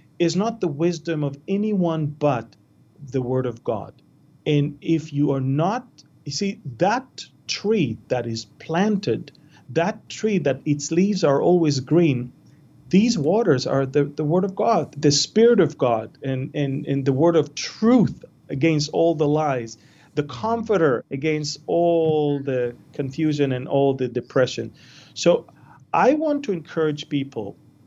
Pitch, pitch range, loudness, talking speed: 150 Hz, 140-170 Hz, -22 LUFS, 150 wpm